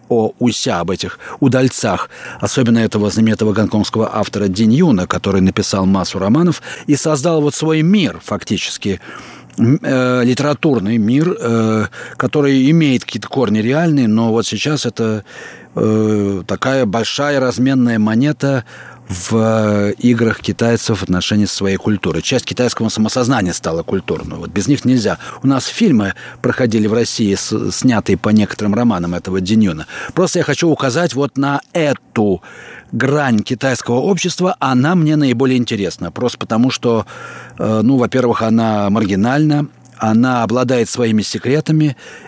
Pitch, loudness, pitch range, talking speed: 115 Hz, -15 LUFS, 105-135 Hz, 130 wpm